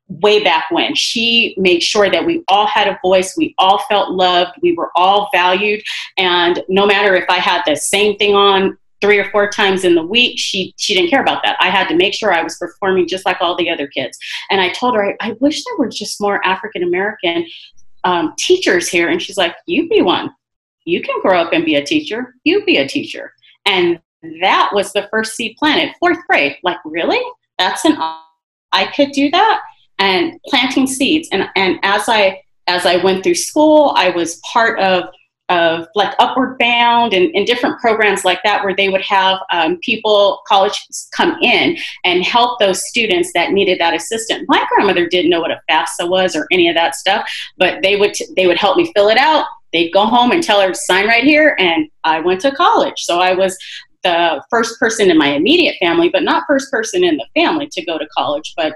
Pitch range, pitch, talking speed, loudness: 185-300 Hz, 205 Hz, 215 wpm, -14 LUFS